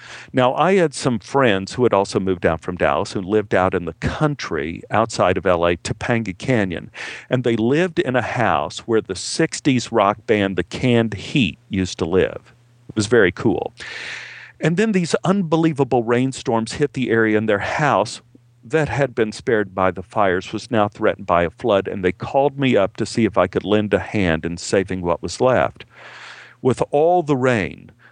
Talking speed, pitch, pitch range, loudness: 190 wpm, 115 Hz, 100-135 Hz, -19 LUFS